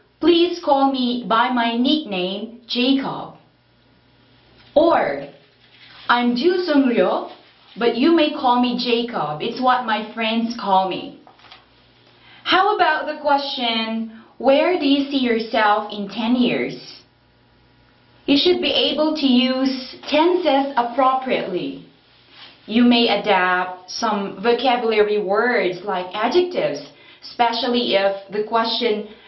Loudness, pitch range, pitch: -19 LUFS, 220-275 Hz, 240 Hz